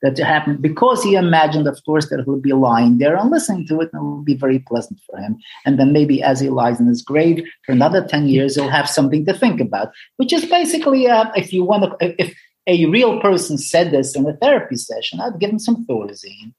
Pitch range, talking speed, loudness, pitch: 135-210 Hz, 245 wpm, -16 LUFS, 155 Hz